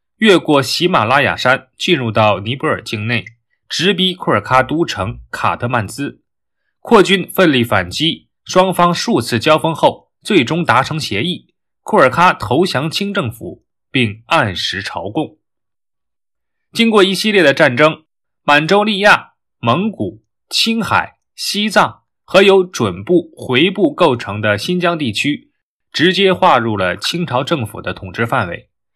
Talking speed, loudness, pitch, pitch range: 215 characters per minute, -14 LUFS, 155 Hz, 115-185 Hz